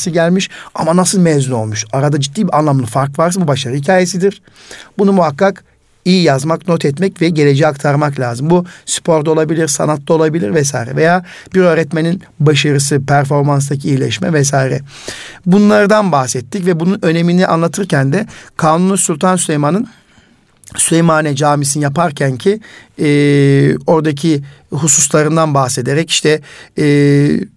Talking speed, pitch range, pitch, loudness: 125 wpm, 145-175 Hz, 155 Hz, -12 LUFS